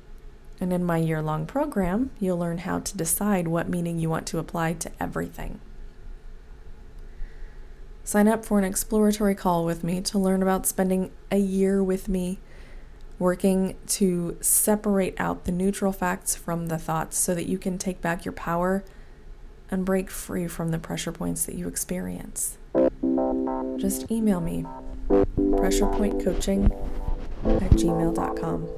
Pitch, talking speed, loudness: 170 Hz, 145 wpm, -25 LUFS